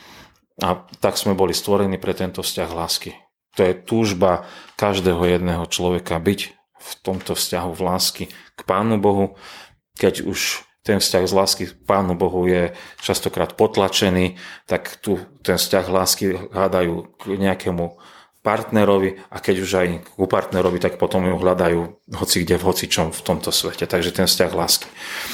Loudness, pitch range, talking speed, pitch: -20 LUFS, 90-100 Hz, 155 wpm, 95 Hz